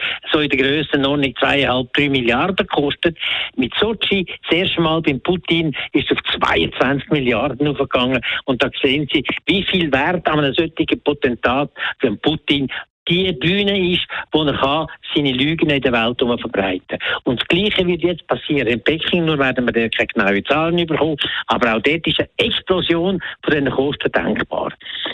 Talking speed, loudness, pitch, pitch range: 170 wpm, -17 LUFS, 150 Hz, 135-170 Hz